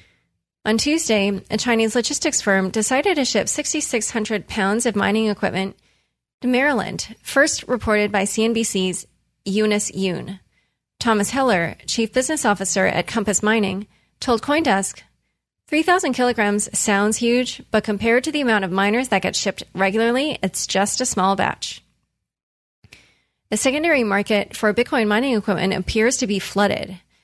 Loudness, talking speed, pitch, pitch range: -20 LUFS, 140 wpm, 215 Hz, 200-245 Hz